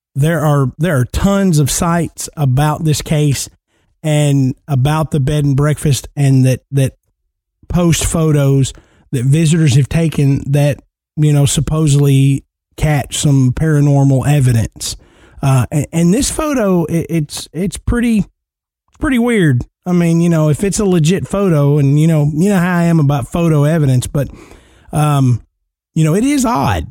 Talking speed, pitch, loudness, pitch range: 160 wpm, 145 Hz, -14 LUFS, 135-165 Hz